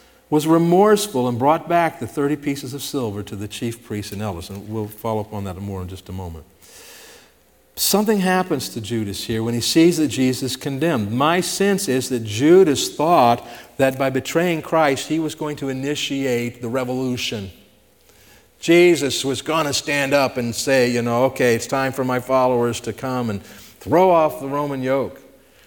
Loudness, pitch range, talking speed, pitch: -19 LUFS, 115-150 Hz, 185 wpm, 130 Hz